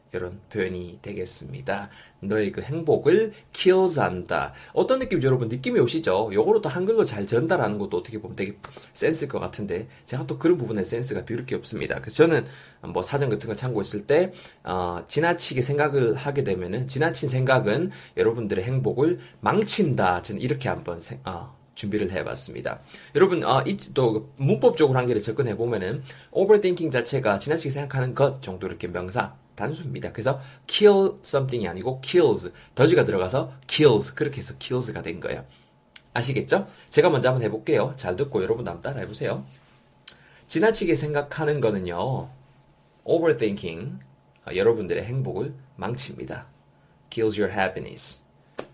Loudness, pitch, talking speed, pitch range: -24 LUFS, 130 Hz, 405 characters per minute, 110-150 Hz